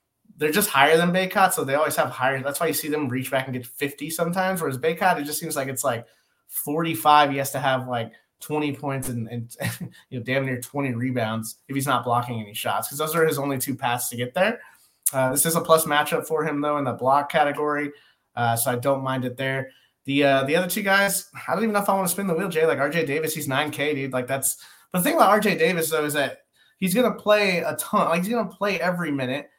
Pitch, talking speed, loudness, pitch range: 145 Hz, 260 wpm, -23 LUFS, 130-165 Hz